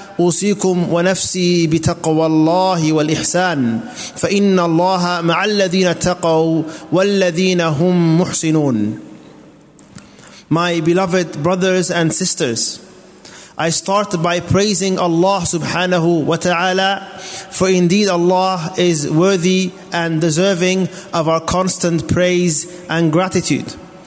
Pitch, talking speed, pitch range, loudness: 175 Hz, 95 wpm, 165-185 Hz, -15 LUFS